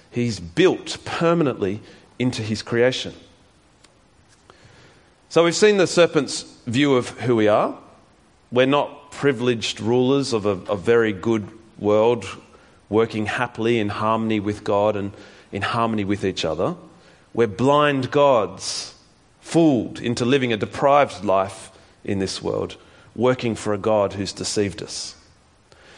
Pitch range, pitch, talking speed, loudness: 100-125 Hz, 115 Hz, 130 wpm, -21 LUFS